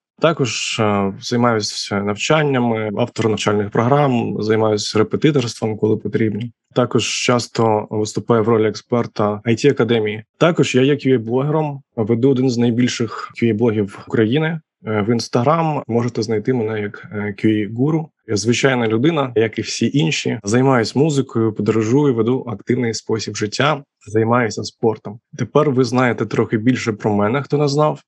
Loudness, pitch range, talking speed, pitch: -18 LUFS, 110-135 Hz, 130 wpm, 115 Hz